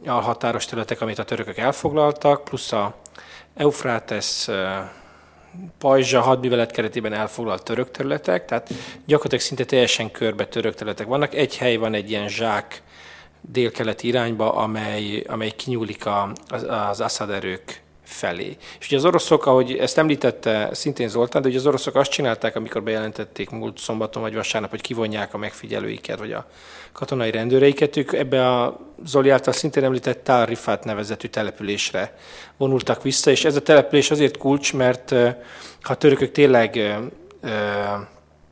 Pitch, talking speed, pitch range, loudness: 120 Hz, 140 wpm, 110-135 Hz, -21 LUFS